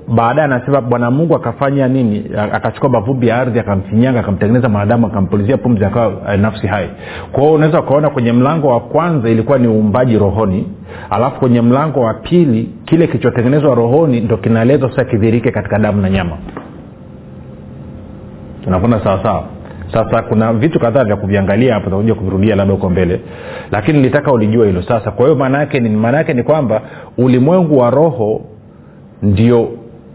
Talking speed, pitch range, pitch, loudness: 125 wpm, 105-130 Hz, 115 Hz, -13 LUFS